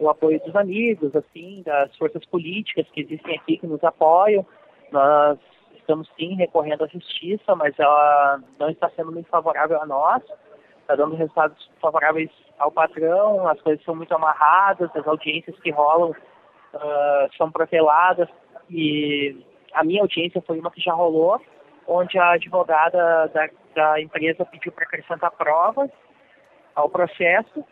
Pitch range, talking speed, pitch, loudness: 155-175 Hz, 145 wpm, 165 Hz, -20 LUFS